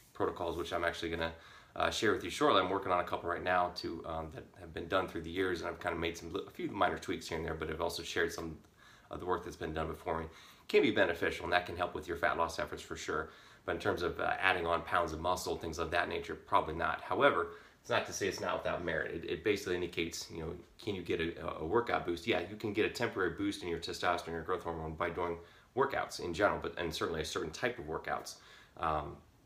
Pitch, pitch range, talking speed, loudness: 85 Hz, 80-90 Hz, 270 wpm, -35 LUFS